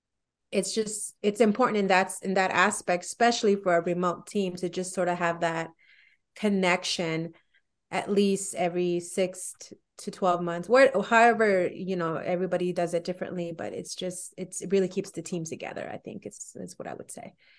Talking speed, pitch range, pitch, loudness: 190 wpm, 175-200 Hz, 185 Hz, -27 LUFS